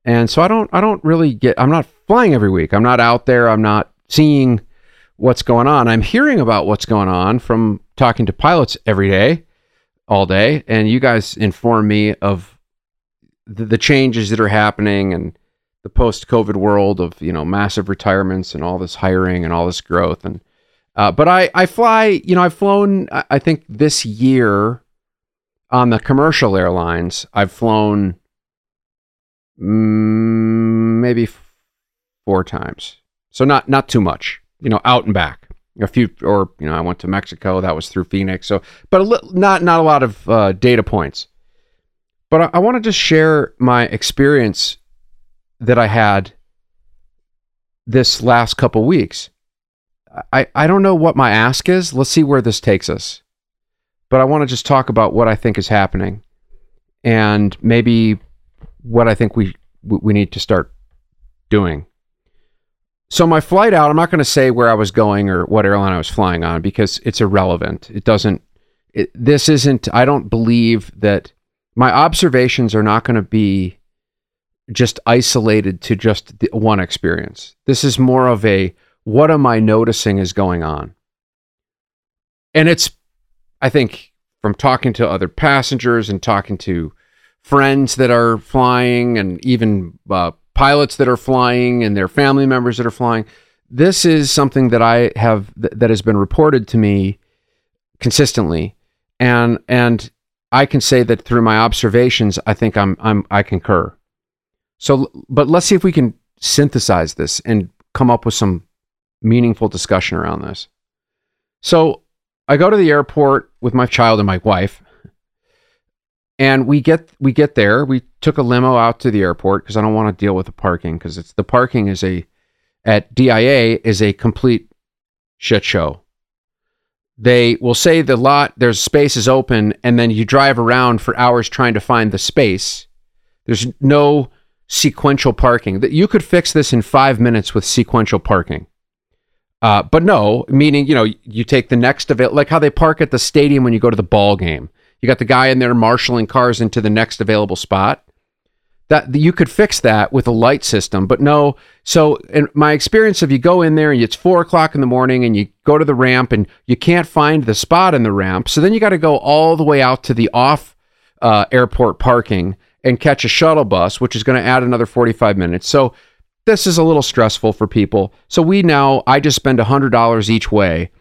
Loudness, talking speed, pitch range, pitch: -13 LUFS, 185 wpm, 100-135 Hz, 115 Hz